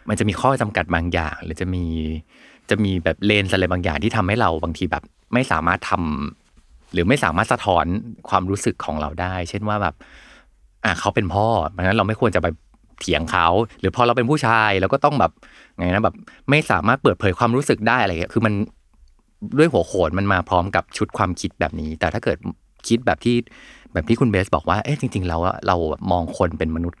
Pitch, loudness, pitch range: 95 Hz, -20 LUFS, 85-115 Hz